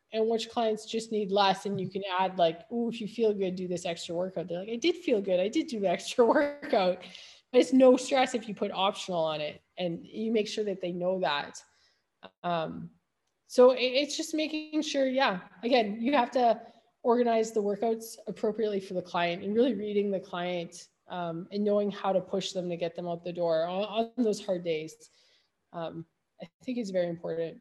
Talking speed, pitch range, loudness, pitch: 210 wpm, 180-235 Hz, -29 LUFS, 205 Hz